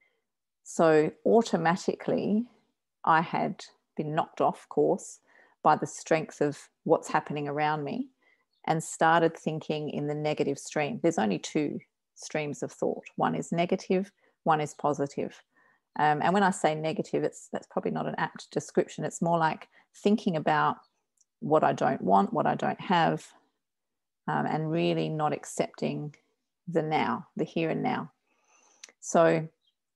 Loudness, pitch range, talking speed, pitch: -28 LUFS, 155-205 Hz, 145 wpm, 165 Hz